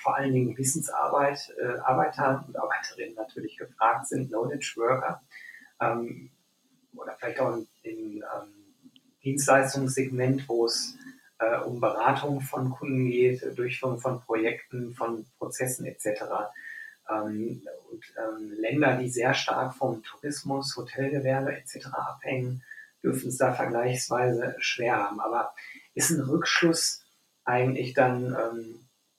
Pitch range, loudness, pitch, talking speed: 125-150 Hz, -28 LUFS, 130 Hz, 120 wpm